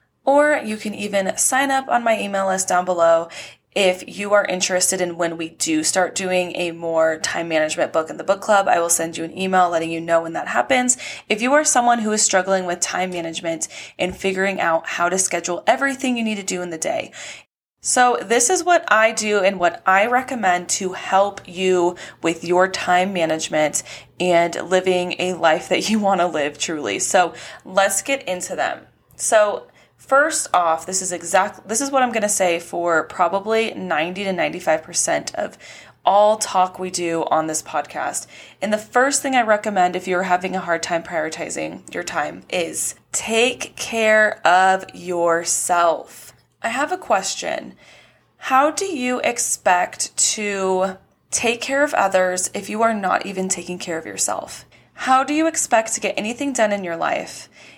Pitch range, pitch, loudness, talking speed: 175-220 Hz, 190 Hz, -19 LUFS, 185 wpm